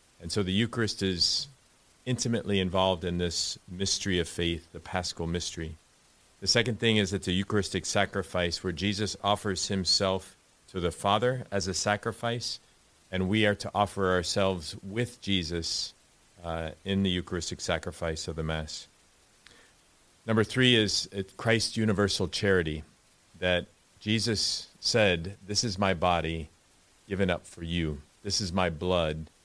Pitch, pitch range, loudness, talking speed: 95 Hz, 85-105 Hz, -29 LUFS, 145 wpm